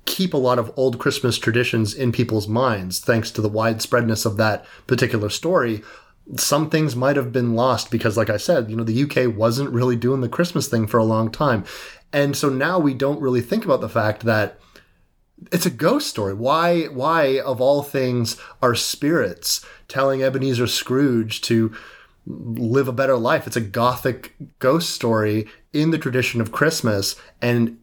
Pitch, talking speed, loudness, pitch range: 125 Hz, 180 wpm, -20 LUFS, 115-140 Hz